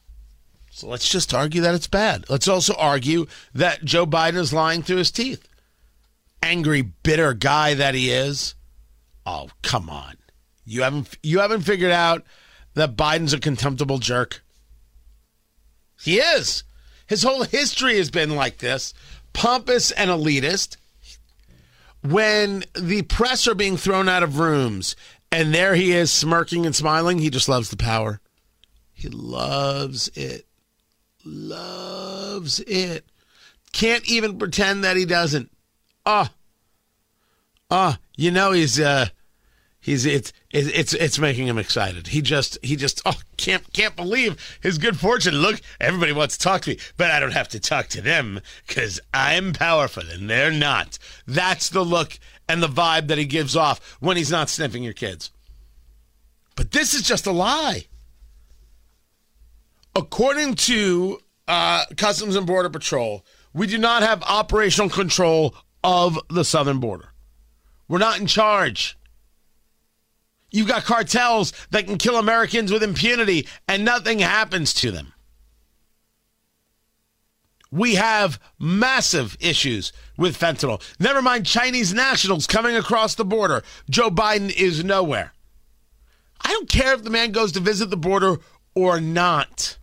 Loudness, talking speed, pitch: -20 LUFS, 145 wpm, 160 Hz